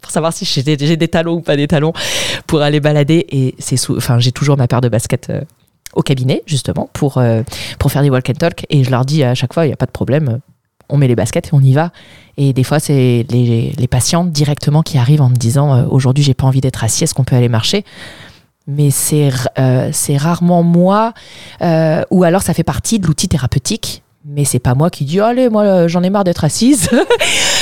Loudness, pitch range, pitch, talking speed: -13 LUFS, 130-165 Hz, 145 Hz, 240 wpm